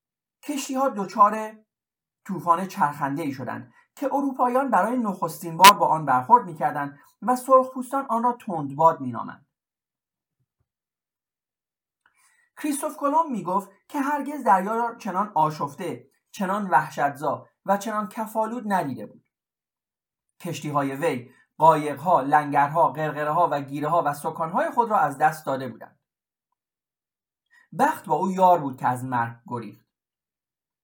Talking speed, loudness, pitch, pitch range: 130 wpm, -23 LUFS, 190 Hz, 150-250 Hz